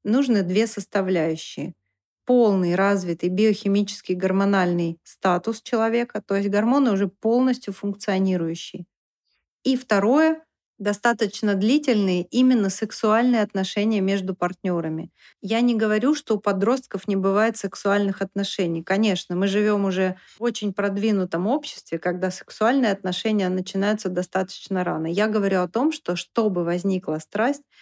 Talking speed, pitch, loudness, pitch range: 120 wpm, 200 Hz, -23 LUFS, 185-220 Hz